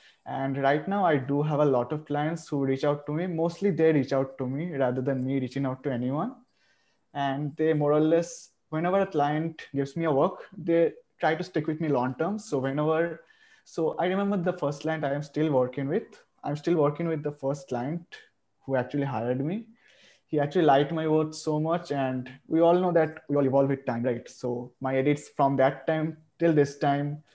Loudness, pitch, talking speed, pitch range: -27 LUFS, 145 Hz, 215 wpm, 135-165 Hz